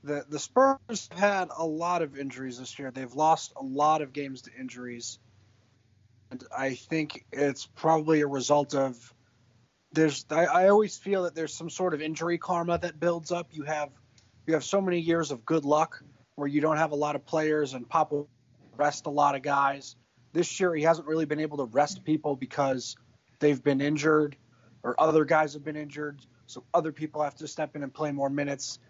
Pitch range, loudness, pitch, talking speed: 130-160 Hz, -28 LUFS, 150 Hz, 205 wpm